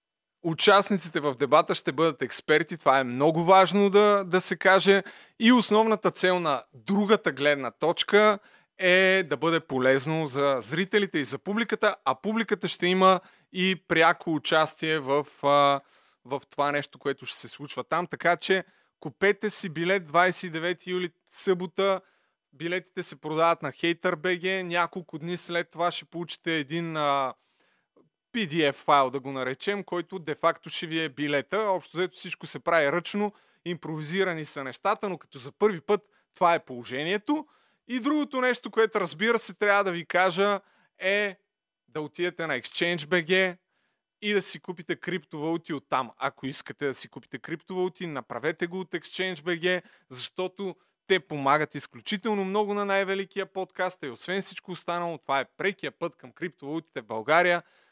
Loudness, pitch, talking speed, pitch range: -26 LUFS, 175 Hz, 150 wpm, 155-190 Hz